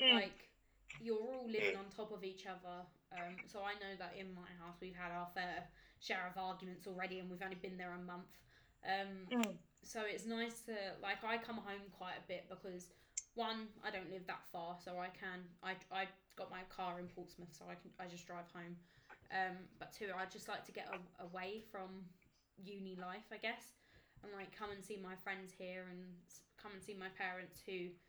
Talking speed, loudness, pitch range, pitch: 210 wpm, -47 LUFS, 180-200 Hz, 190 Hz